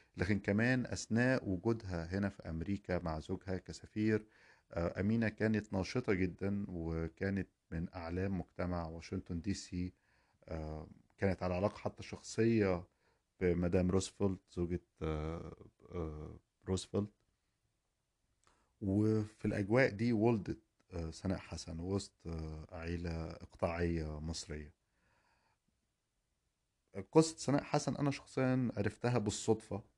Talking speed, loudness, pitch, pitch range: 95 wpm, -38 LUFS, 95 Hz, 85-110 Hz